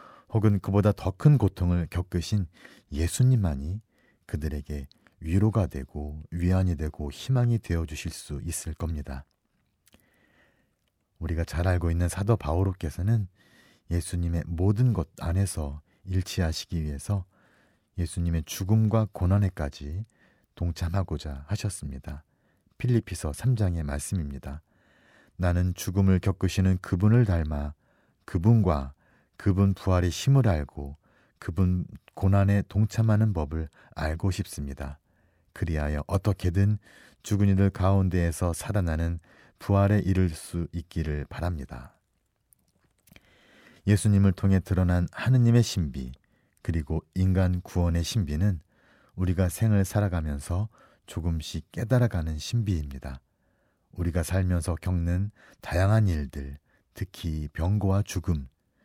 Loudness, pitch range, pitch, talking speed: -27 LUFS, 80-100 Hz, 90 Hz, 265 characters per minute